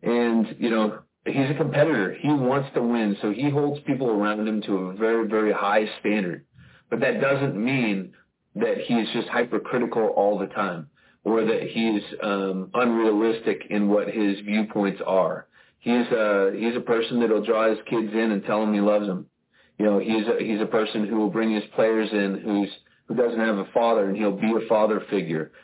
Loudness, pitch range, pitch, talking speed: -24 LUFS, 105-115 Hz, 110 Hz, 195 wpm